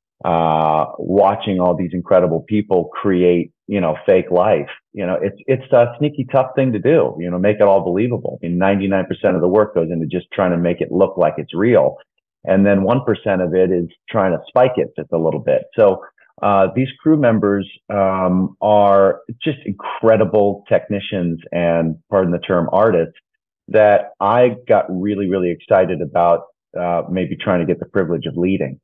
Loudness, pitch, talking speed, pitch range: -17 LUFS, 95 Hz, 190 wpm, 90-105 Hz